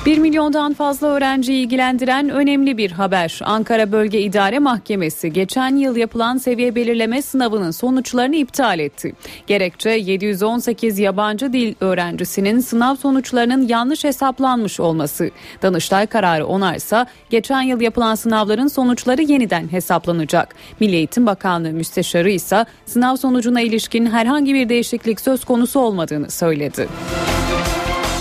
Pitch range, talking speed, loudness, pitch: 195-260 Hz, 120 wpm, -17 LUFS, 230 Hz